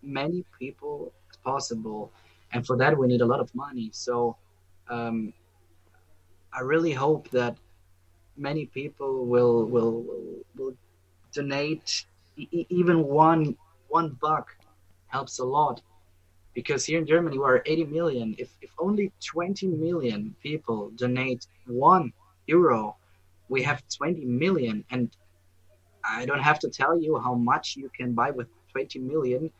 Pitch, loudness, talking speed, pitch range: 125 Hz, -27 LUFS, 140 wpm, 95-150 Hz